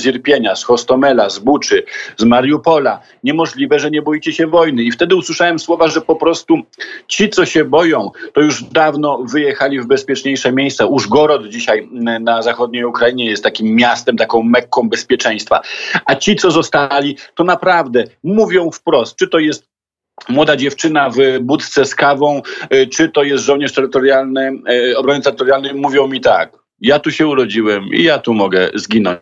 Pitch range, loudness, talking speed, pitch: 130-165 Hz, -13 LUFS, 160 wpm, 140 Hz